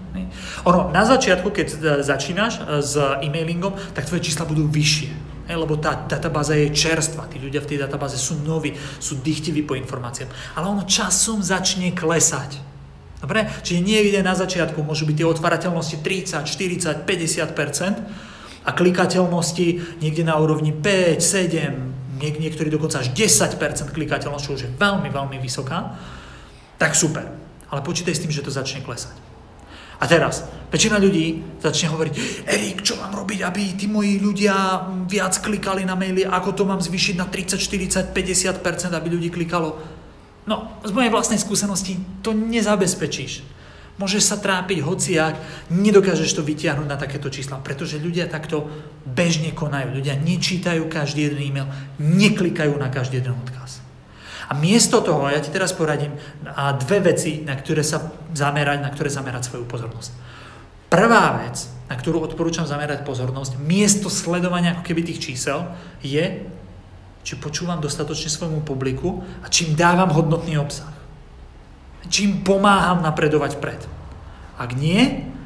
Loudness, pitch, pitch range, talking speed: -20 LUFS, 160 Hz, 145-185 Hz, 145 wpm